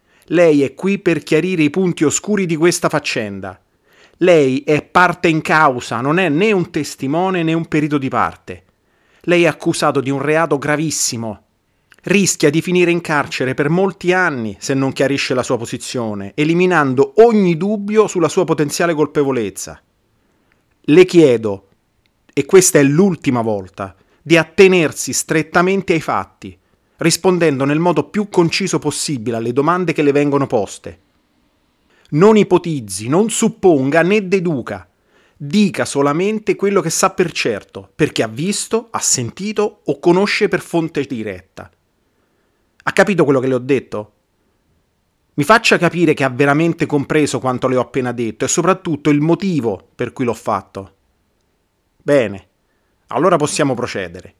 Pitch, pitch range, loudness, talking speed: 150 Hz, 125-175 Hz, -15 LUFS, 145 wpm